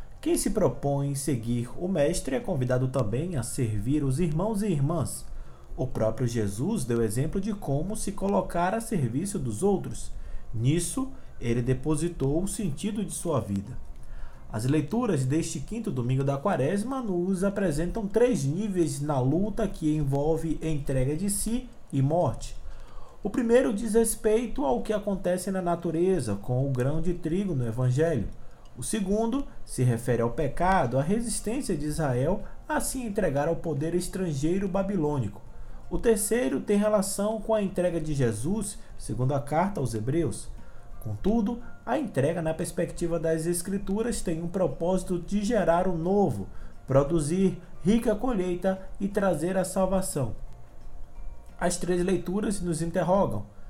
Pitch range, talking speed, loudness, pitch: 130-200 Hz, 145 wpm, -28 LUFS, 170 Hz